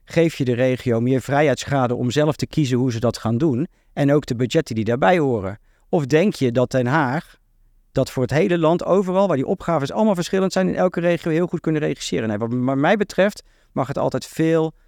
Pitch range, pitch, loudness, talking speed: 125-170 Hz, 145 Hz, -20 LUFS, 220 wpm